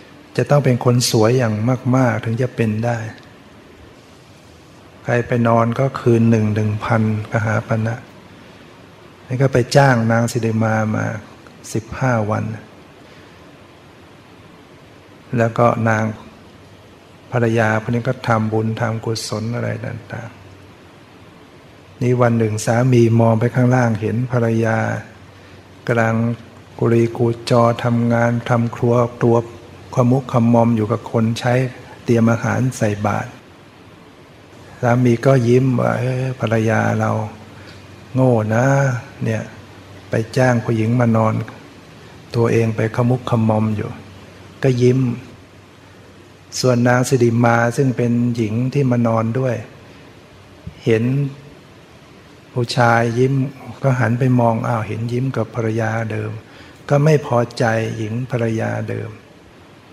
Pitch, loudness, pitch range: 115 Hz, -17 LUFS, 110-125 Hz